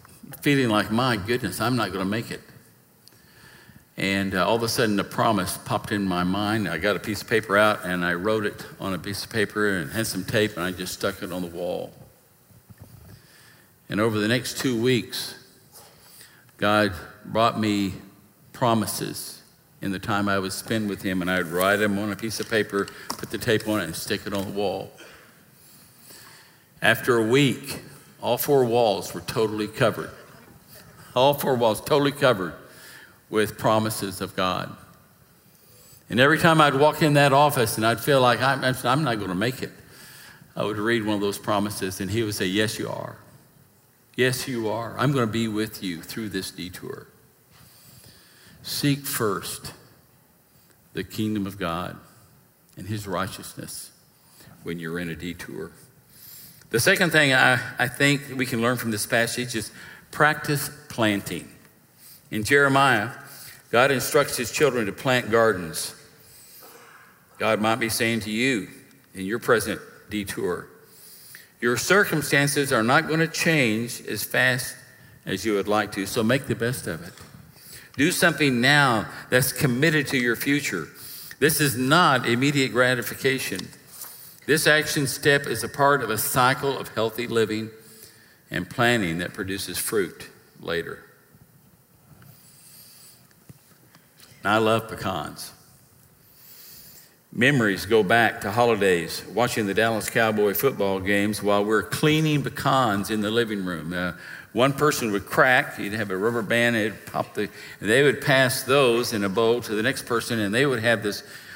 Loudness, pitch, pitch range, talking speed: -23 LUFS, 115 Hz, 100-130 Hz, 160 wpm